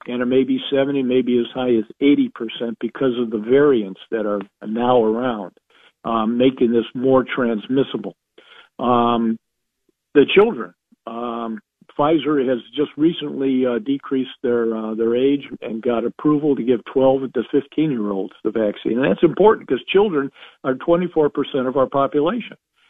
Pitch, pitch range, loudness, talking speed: 130 Hz, 115-140 Hz, -19 LUFS, 160 wpm